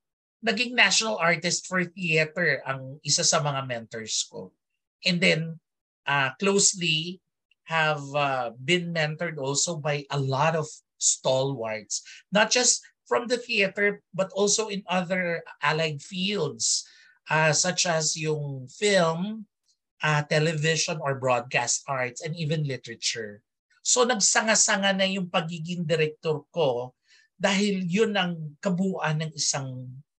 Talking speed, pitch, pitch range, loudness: 125 wpm, 165 Hz, 145-195 Hz, -25 LUFS